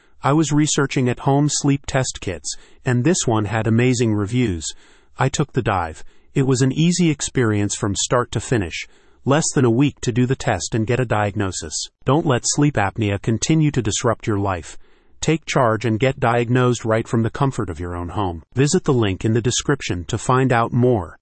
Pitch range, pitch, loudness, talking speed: 105-135 Hz, 120 Hz, -19 LUFS, 200 wpm